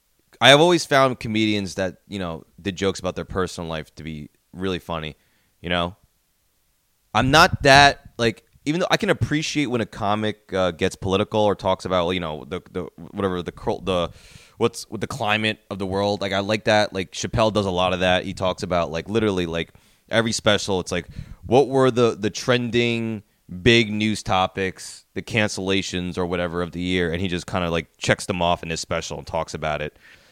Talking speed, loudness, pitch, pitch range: 205 wpm, -21 LUFS, 95 Hz, 90-110 Hz